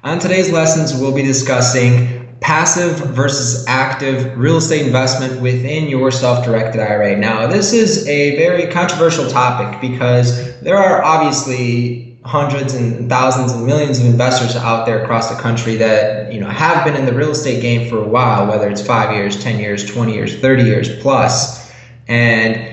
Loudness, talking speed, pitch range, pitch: -14 LUFS, 170 wpm, 115-140 Hz, 125 Hz